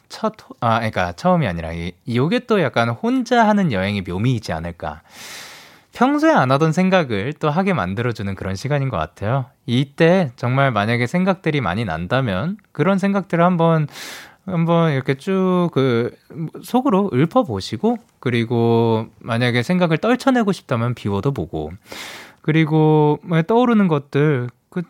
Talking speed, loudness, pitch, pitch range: 310 characters per minute, -19 LUFS, 145 Hz, 115-180 Hz